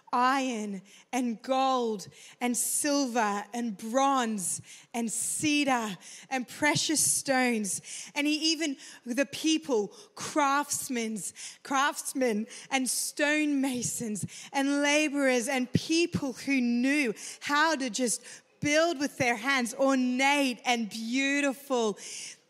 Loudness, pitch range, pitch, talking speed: -28 LUFS, 230-280 Hz, 260 Hz, 95 wpm